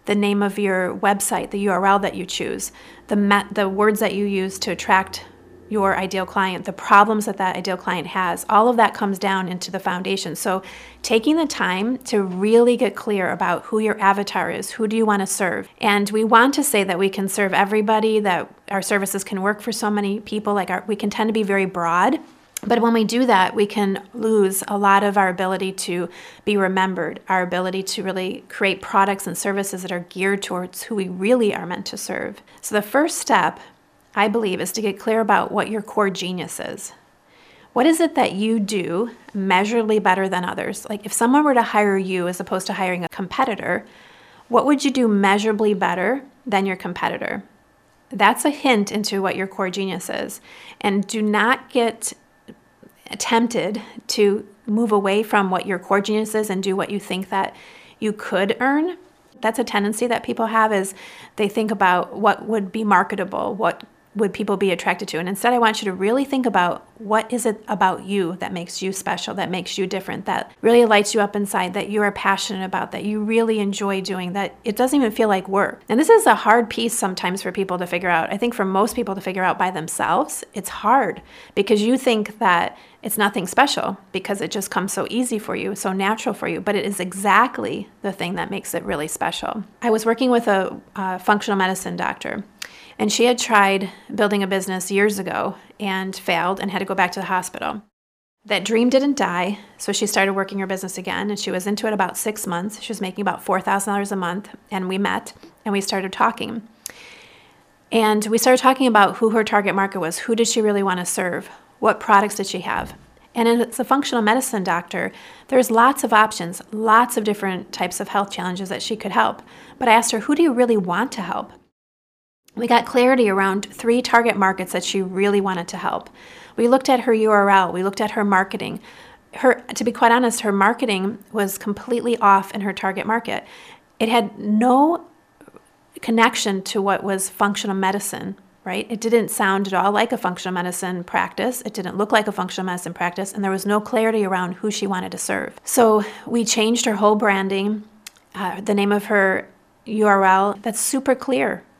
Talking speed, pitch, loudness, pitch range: 205 wpm, 205 Hz, -20 LUFS, 190-225 Hz